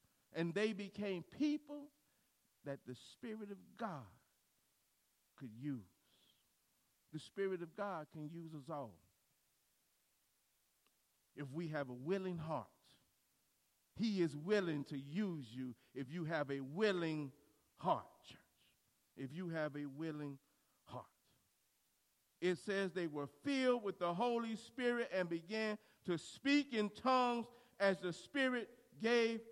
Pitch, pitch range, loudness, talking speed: 180 Hz, 145-220 Hz, -42 LUFS, 130 wpm